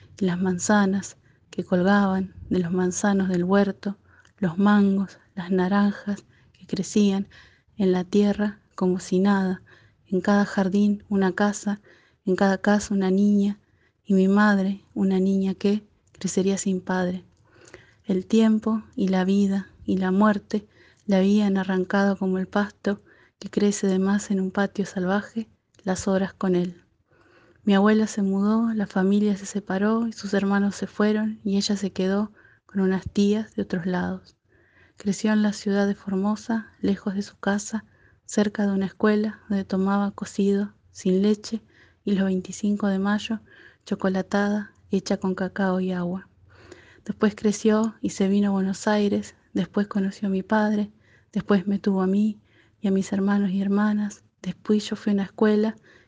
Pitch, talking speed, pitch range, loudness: 200 Hz, 160 wpm, 190-210 Hz, -24 LUFS